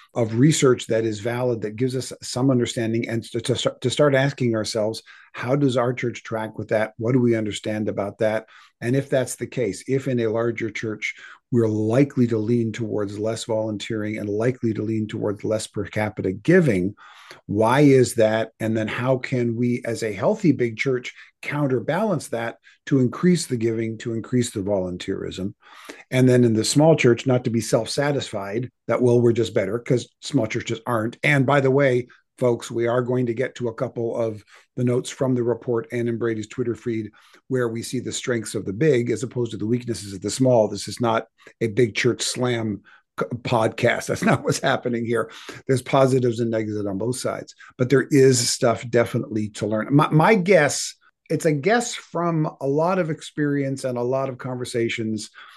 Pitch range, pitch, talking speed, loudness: 110-130 Hz, 120 Hz, 200 wpm, -22 LUFS